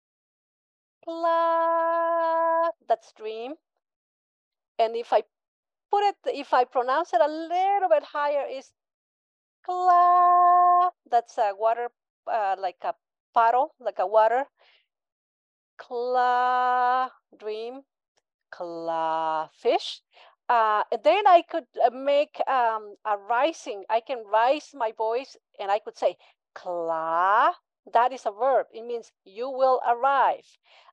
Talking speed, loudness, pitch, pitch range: 115 wpm, -24 LUFS, 255 Hz, 225-330 Hz